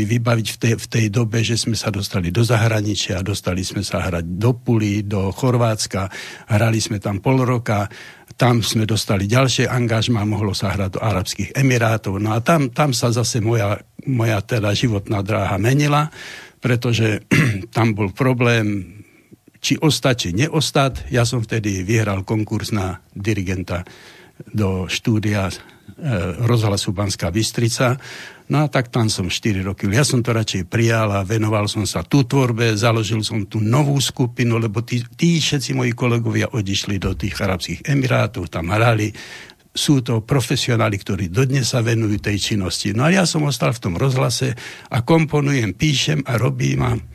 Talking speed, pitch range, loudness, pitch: 160 wpm, 105-125 Hz, -19 LUFS, 115 Hz